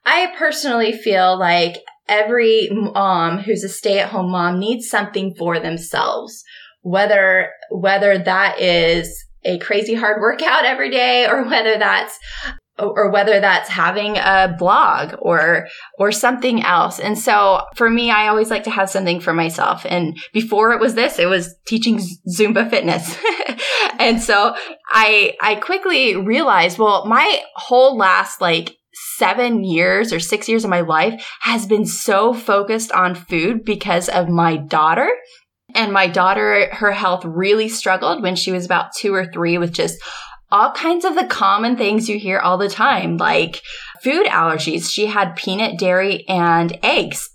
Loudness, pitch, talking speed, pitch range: -16 LUFS, 205 Hz, 160 wpm, 185-225 Hz